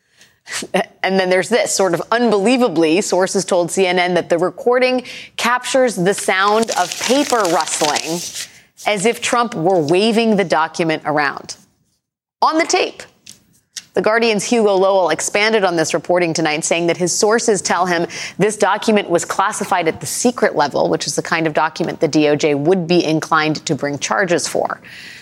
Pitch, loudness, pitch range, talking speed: 185 Hz, -16 LUFS, 165-220 Hz, 160 wpm